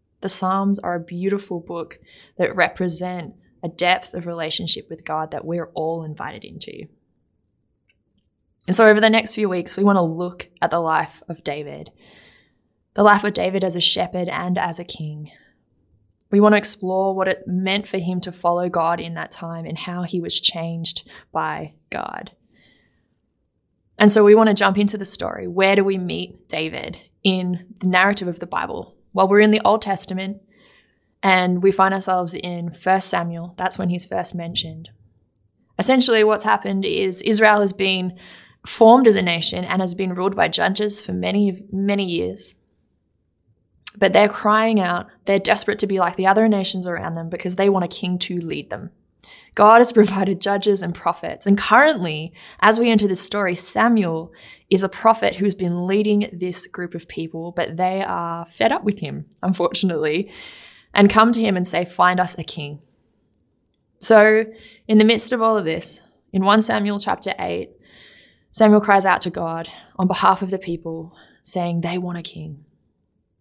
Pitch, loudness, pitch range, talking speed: 185 Hz, -18 LUFS, 170-200 Hz, 180 wpm